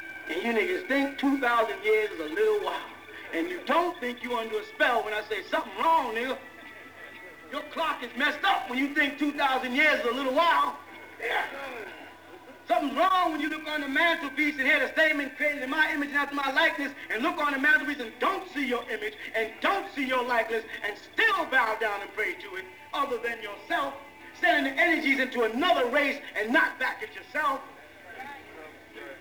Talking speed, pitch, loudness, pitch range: 195 wpm, 295 Hz, -27 LUFS, 255-330 Hz